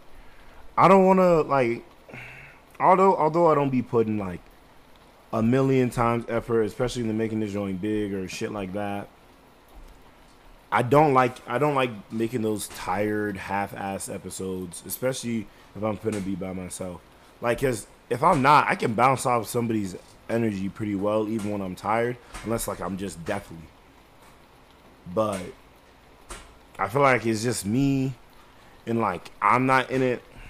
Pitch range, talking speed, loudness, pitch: 100-125 Hz, 155 wpm, -24 LUFS, 110 Hz